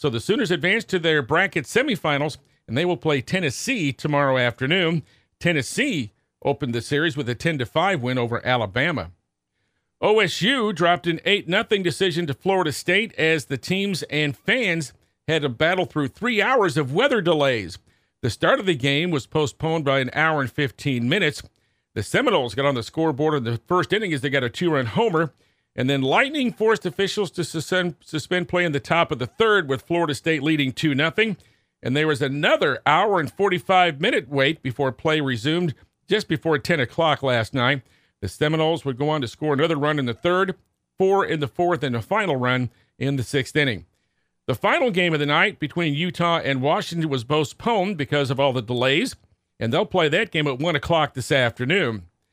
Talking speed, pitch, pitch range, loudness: 190 wpm, 155 Hz, 135-175 Hz, -22 LUFS